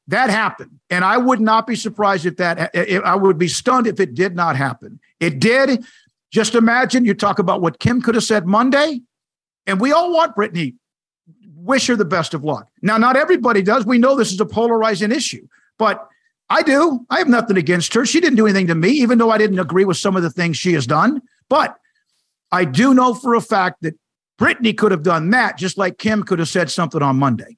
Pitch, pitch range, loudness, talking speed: 210 Hz, 180-245 Hz, -16 LUFS, 225 wpm